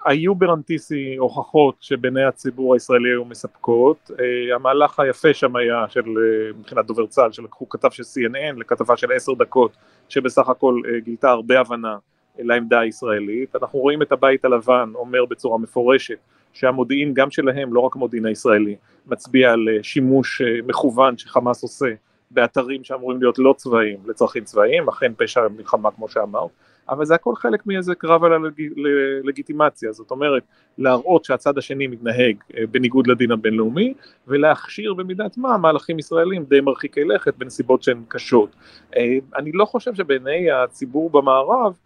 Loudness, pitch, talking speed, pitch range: -19 LUFS, 130 Hz, 150 wpm, 120-150 Hz